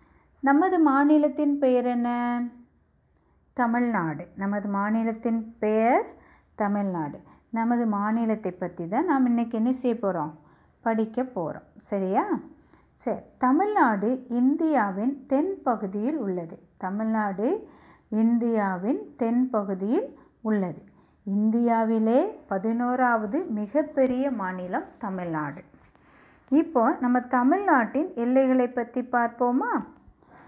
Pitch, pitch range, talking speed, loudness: 235 Hz, 205-260 Hz, 85 wpm, -25 LUFS